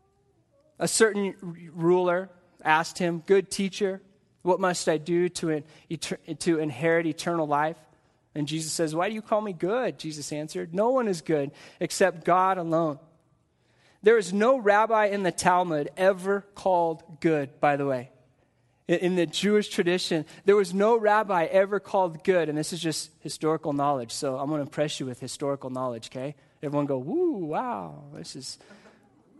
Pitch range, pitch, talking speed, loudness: 150-190 Hz, 170 Hz, 170 wpm, -26 LUFS